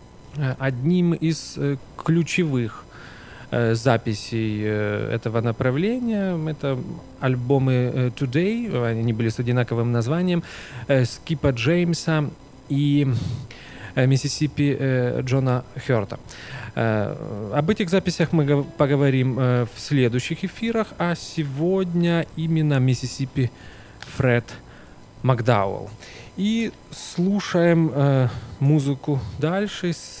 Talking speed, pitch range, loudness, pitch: 75 wpm, 125-160 Hz, -23 LUFS, 135 Hz